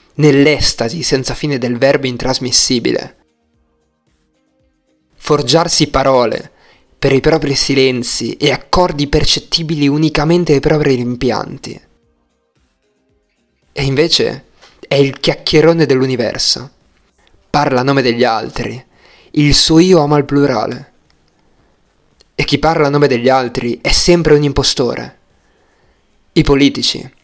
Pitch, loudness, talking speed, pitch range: 140 Hz, -12 LUFS, 110 wpm, 130-150 Hz